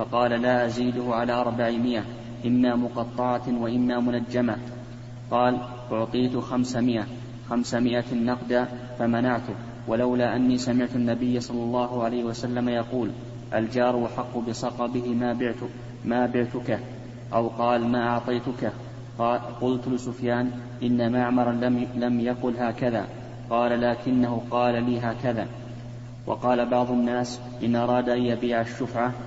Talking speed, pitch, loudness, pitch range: 115 wpm, 120 Hz, -26 LUFS, 120-125 Hz